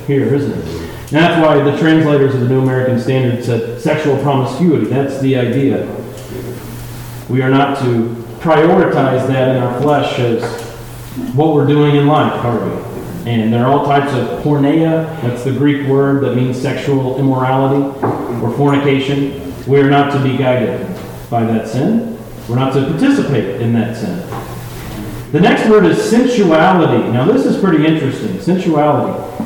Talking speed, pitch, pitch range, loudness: 165 wpm, 135 Hz, 120-145 Hz, -13 LUFS